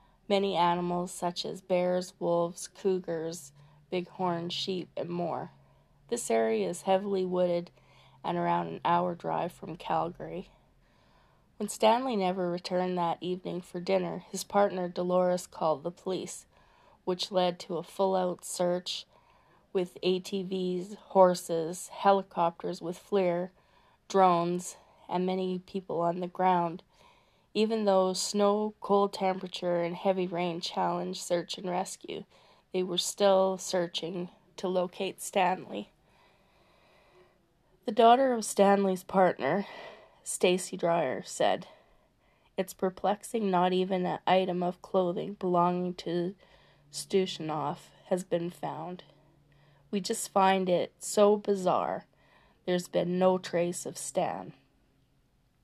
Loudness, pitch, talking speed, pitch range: -30 LUFS, 185 Hz, 120 wpm, 175-195 Hz